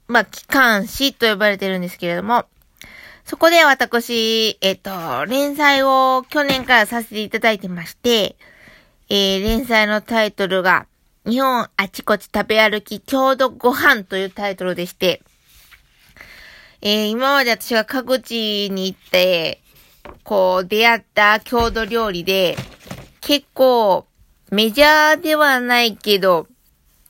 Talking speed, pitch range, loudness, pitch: 250 characters per minute, 195-260 Hz, -16 LUFS, 220 Hz